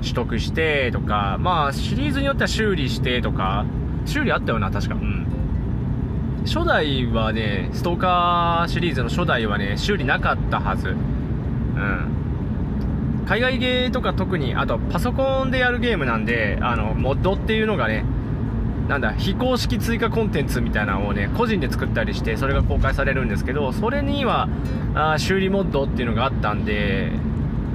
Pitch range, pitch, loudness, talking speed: 110-140 Hz, 120 Hz, -22 LUFS, 345 characters per minute